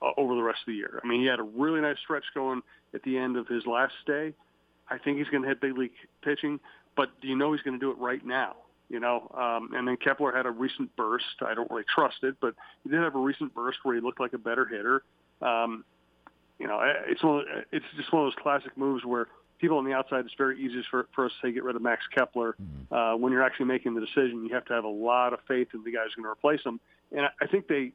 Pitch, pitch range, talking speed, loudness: 130 Hz, 120-140 Hz, 275 wpm, -29 LUFS